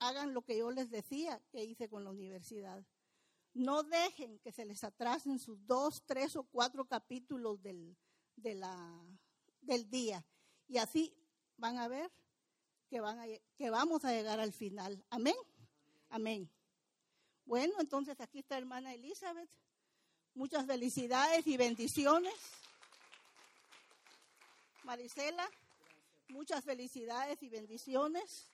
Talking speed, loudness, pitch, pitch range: 125 wpm, -40 LUFS, 250 Hz, 220-290 Hz